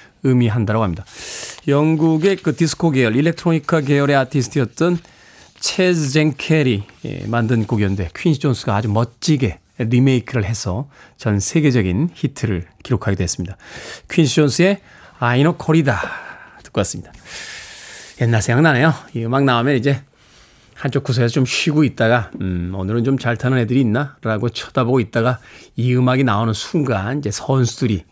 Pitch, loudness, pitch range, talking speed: 130 Hz, -18 LUFS, 115-155 Hz, 335 characters per minute